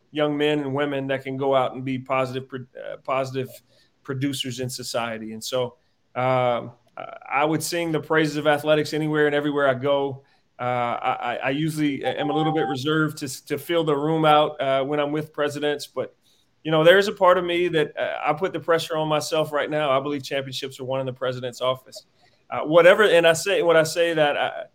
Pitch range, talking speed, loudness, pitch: 130-155 Hz, 215 wpm, -22 LUFS, 145 Hz